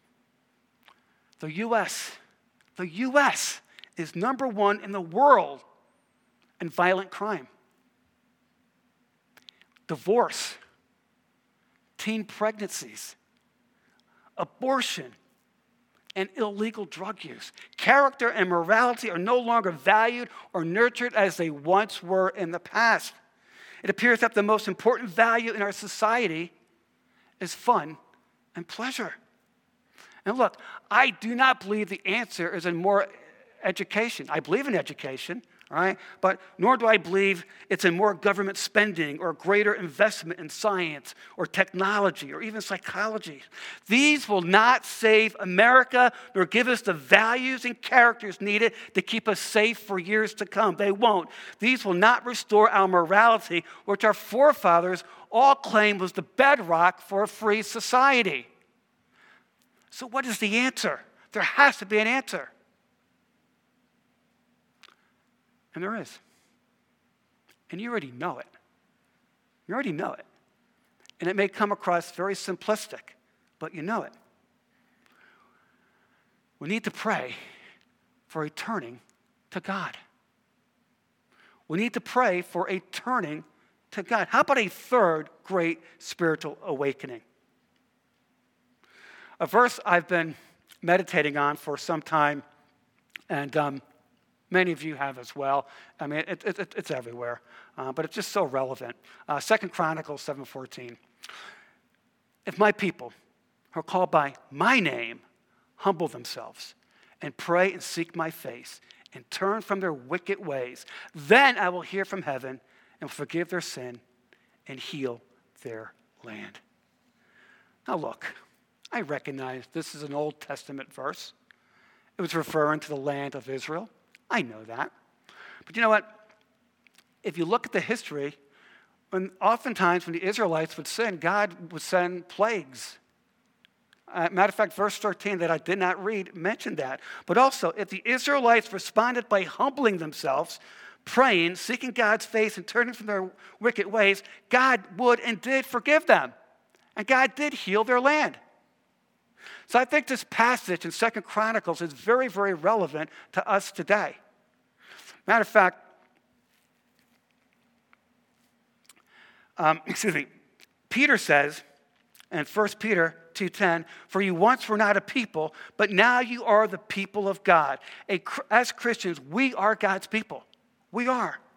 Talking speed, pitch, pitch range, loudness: 140 wpm, 200 Hz, 170-230 Hz, -25 LUFS